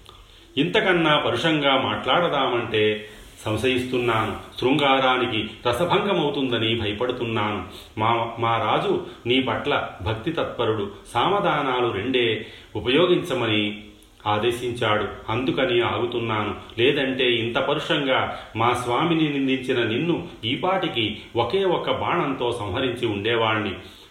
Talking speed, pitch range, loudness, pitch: 80 wpm, 105-130 Hz, -22 LUFS, 120 Hz